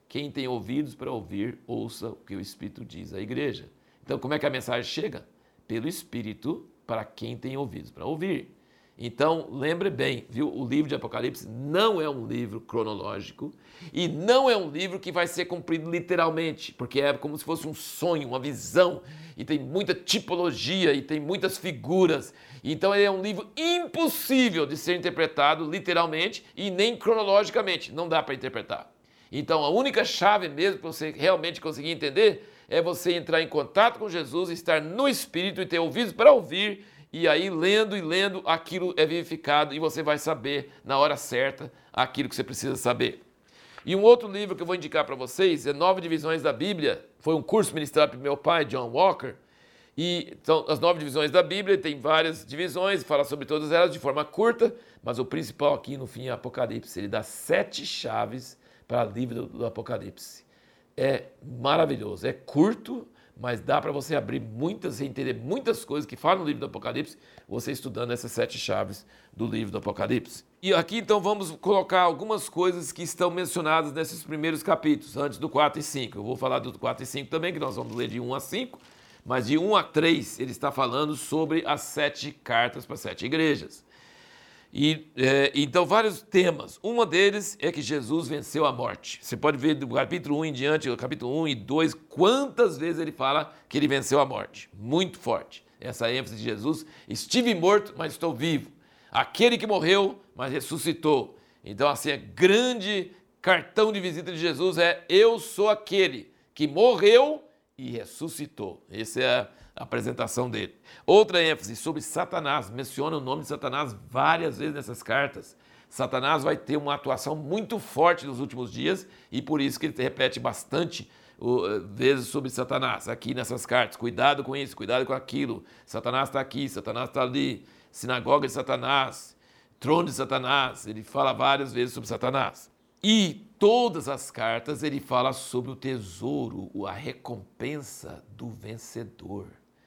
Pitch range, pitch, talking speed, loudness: 140-185 Hz, 155 Hz, 180 wpm, -26 LUFS